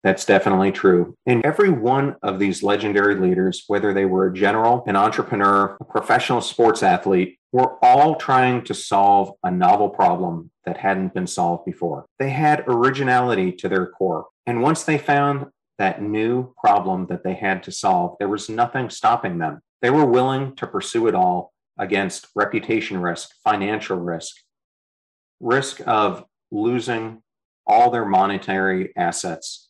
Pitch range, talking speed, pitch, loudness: 95-125 Hz, 155 wpm, 100 Hz, -20 LUFS